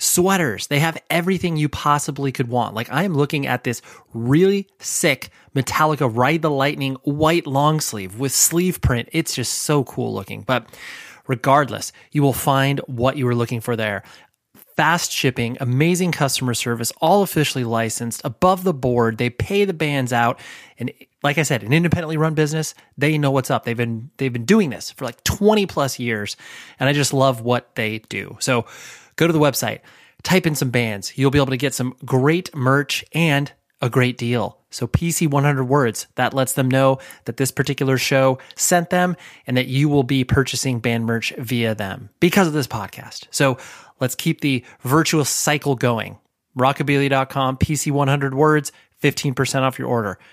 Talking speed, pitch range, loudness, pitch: 185 wpm, 125-155 Hz, -20 LUFS, 135 Hz